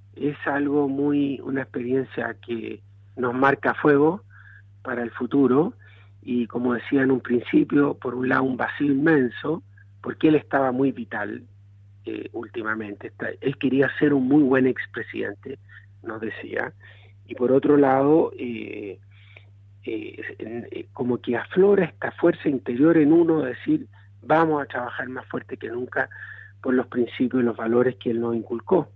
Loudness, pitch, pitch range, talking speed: -23 LUFS, 125 Hz, 110-140 Hz, 150 wpm